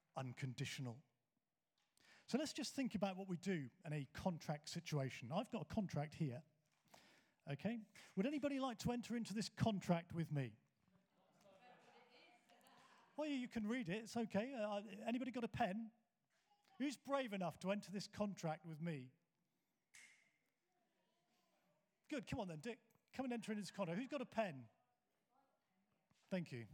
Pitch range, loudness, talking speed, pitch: 160-235 Hz, -46 LUFS, 150 wpm, 200 Hz